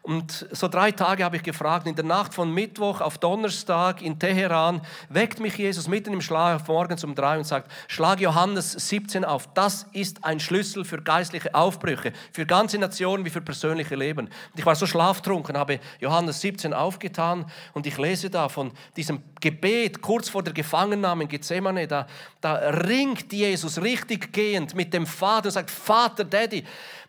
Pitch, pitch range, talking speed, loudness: 175 Hz, 160-195 Hz, 175 wpm, -25 LUFS